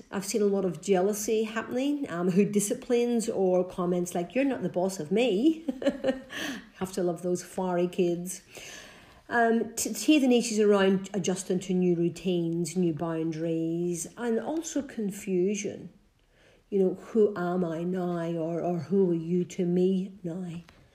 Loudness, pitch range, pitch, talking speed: -28 LUFS, 175-225 Hz, 190 Hz, 160 wpm